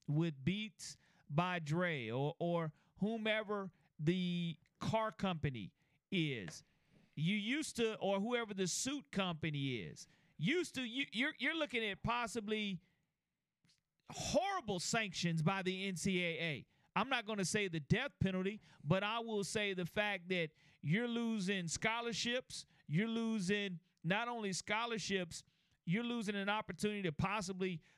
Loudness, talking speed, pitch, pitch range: -39 LUFS, 135 wpm, 190 Hz, 165-215 Hz